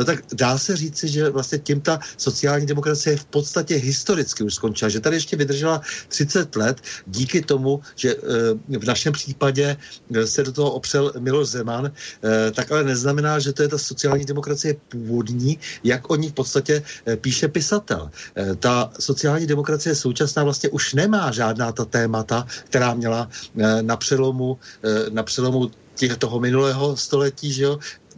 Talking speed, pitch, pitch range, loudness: 155 wpm, 140 Hz, 120-150 Hz, -21 LUFS